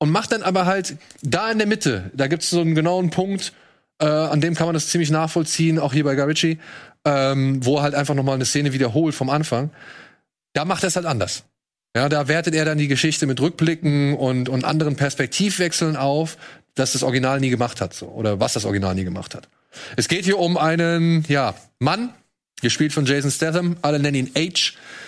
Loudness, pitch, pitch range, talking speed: -20 LUFS, 150 Hz, 135-165 Hz, 215 wpm